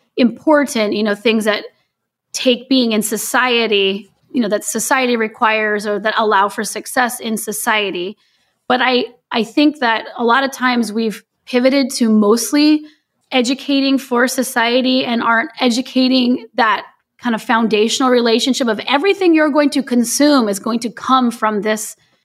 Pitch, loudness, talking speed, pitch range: 235 Hz, -15 LUFS, 155 wpm, 220-260 Hz